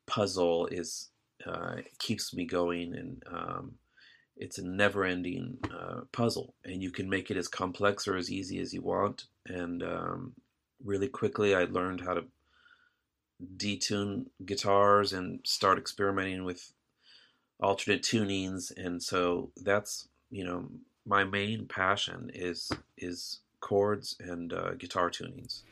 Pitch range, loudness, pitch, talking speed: 90-100 Hz, -33 LUFS, 95 Hz, 135 wpm